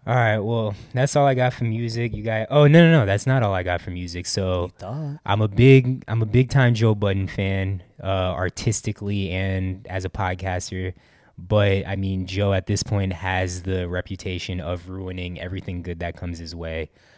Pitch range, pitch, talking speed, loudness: 90-115 Hz, 95 Hz, 200 wpm, -22 LUFS